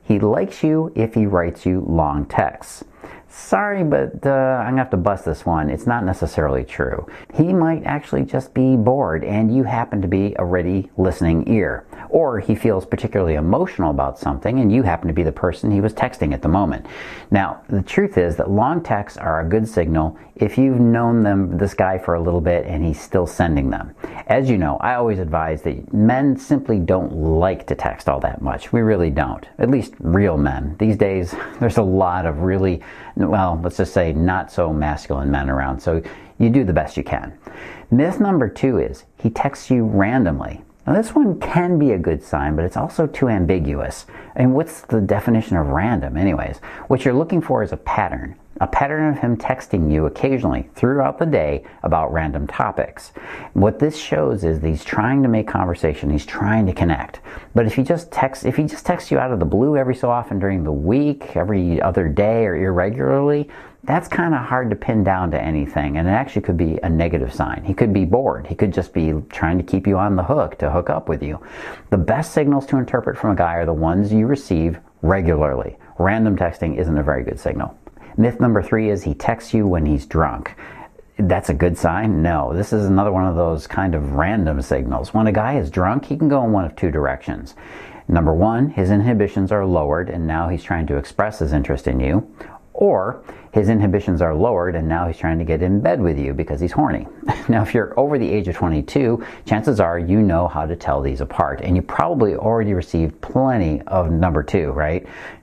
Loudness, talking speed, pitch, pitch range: -19 LUFS, 215 wpm, 95 Hz, 80-115 Hz